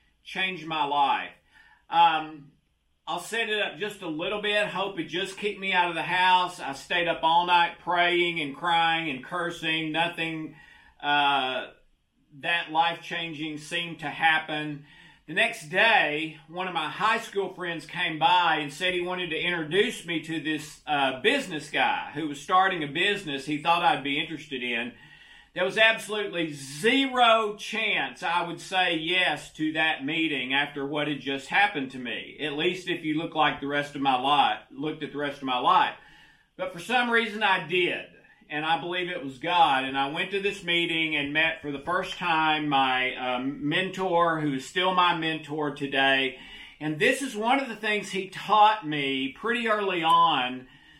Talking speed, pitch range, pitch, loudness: 185 wpm, 150-185 Hz, 165 Hz, -26 LUFS